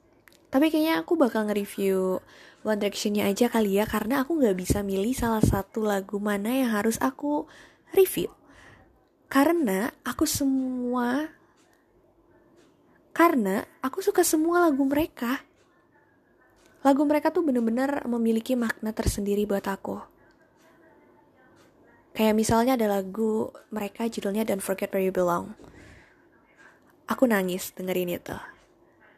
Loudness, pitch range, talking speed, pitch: -26 LUFS, 205-305 Hz, 115 wpm, 240 Hz